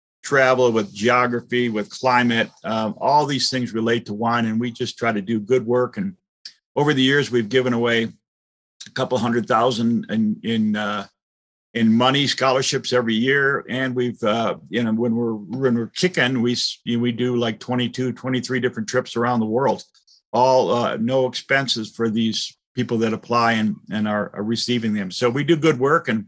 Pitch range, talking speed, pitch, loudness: 115-130 Hz, 185 wpm, 120 Hz, -20 LUFS